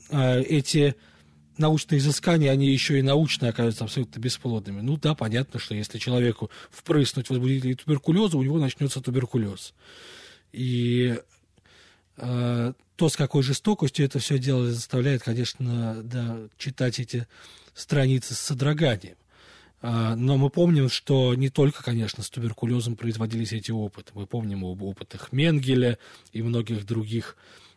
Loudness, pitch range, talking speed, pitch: -25 LUFS, 115-140 Hz, 130 wpm, 125 Hz